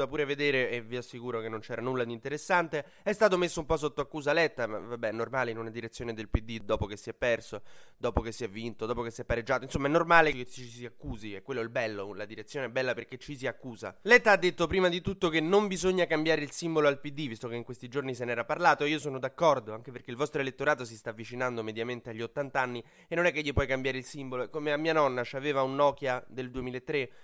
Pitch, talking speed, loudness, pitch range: 130 Hz, 260 wpm, -30 LUFS, 120-150 Hz